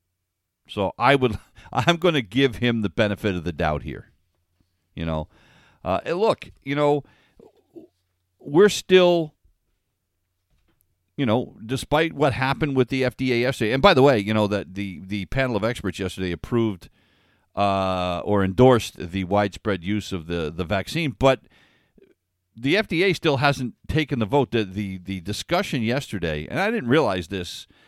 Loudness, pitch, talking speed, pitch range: -22 LUFS, 105 Hz, 155 wpm, 90-135 Hz